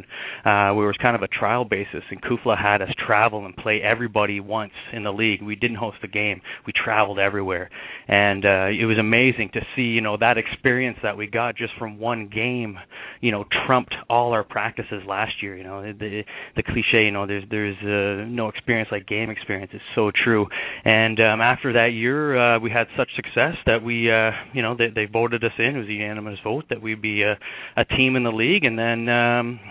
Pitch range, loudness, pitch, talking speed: 105-120 Hz, -21 LUFS, 110 Hz, 220 wpm